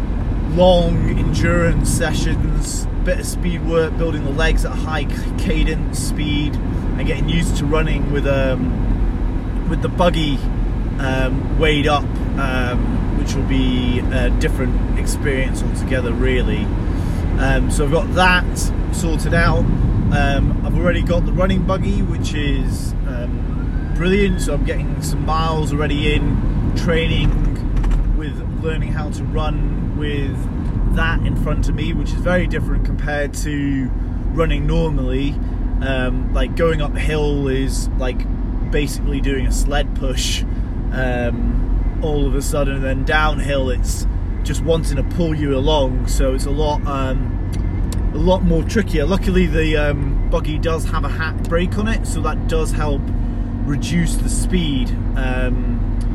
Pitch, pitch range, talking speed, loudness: 110 Hz, 85-130 Hz, 145 wpm, -19 LUFS